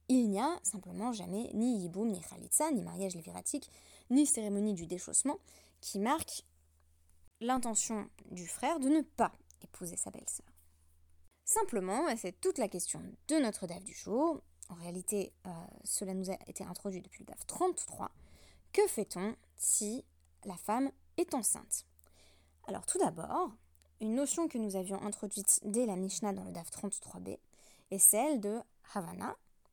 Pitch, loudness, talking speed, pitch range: 205 Hz, -35 LUFS, 155 wpm, 175-245 Hz